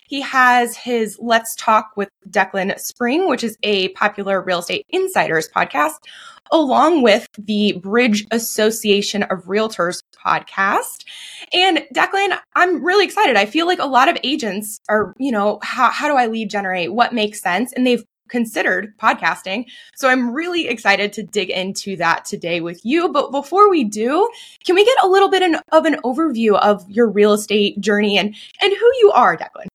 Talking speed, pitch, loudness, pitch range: 175 wpm, 230 Hz, -17 LUFS, 205-315 Hz